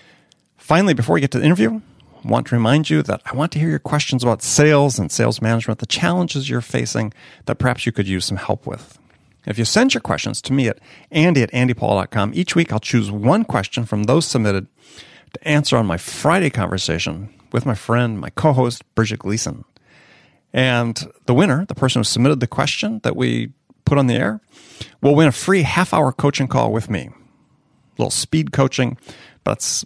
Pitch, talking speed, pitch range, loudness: 125 Hz, 200 wpm, 110-150 Hz, -18 LUFS